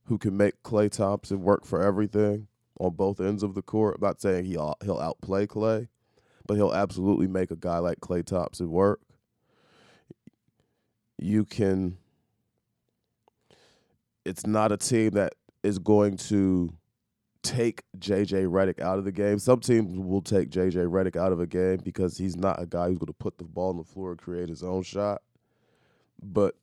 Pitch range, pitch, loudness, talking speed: 90-105 Hz, 95 Hz, -27 LUFS, 175 wpm